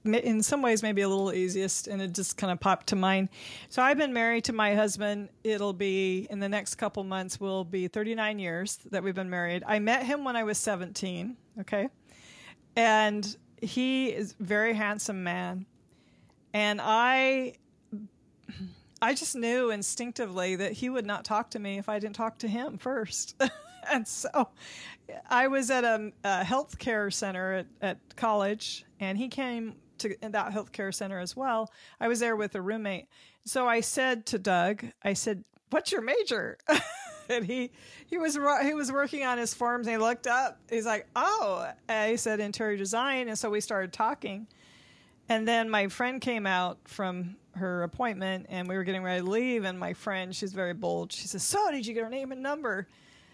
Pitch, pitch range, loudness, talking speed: 215 Hz, 195-245 Hz, -30 LUFS, 190 wpm